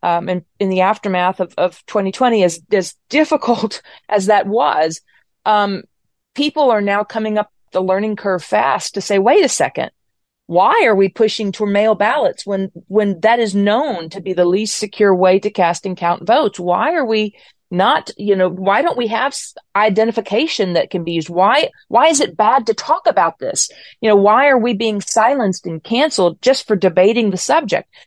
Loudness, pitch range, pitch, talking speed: -15 LUFS, 185-225 Hz, 205 Hz, 195 wpm